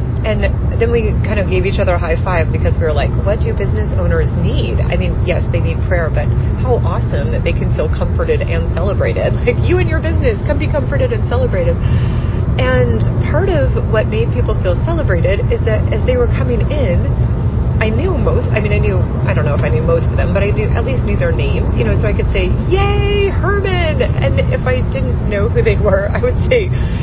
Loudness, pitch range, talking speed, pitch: -15 LUFS, 100-120 Hz, 230 wpm, 110 Hz